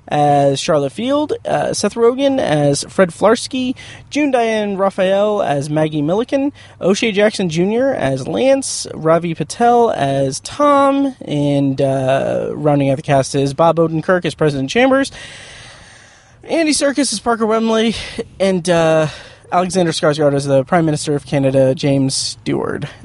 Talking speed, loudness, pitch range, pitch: 140 wpm, -15 LUFS, 145-230 Hz, 170 Hz